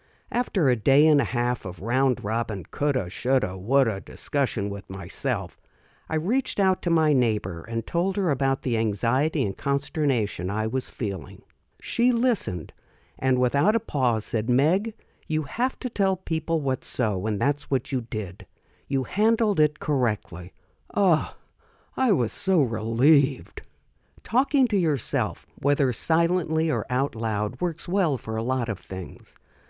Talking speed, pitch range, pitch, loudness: 155 wpm, 110-160 Hz, 130 Hz, -25 LUFS